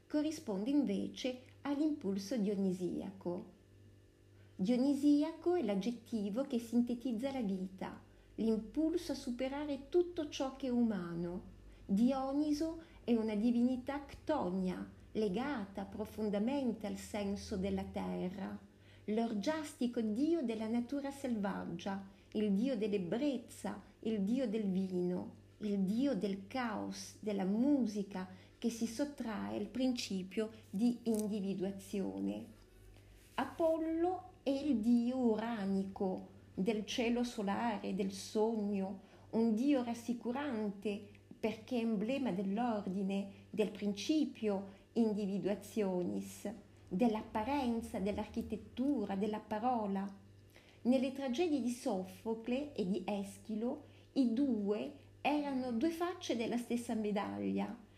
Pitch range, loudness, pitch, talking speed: 195-260 Hz, -38 LUFS, 220 Hz, 95 wpm